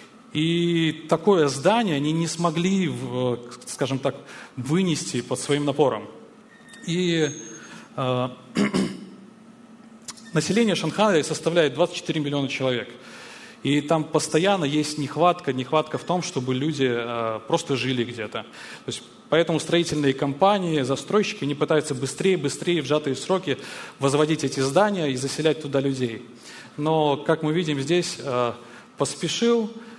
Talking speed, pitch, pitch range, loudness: 120 wpm, 155 Hz, 135-175 Hz, -24 LUFS